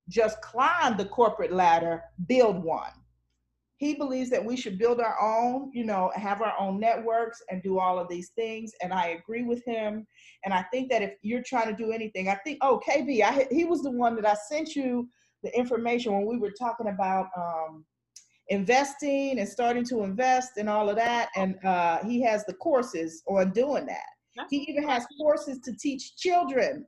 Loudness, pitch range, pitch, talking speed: -27 LUFS, 190-255 Hz, 230 Hz, 195 wpm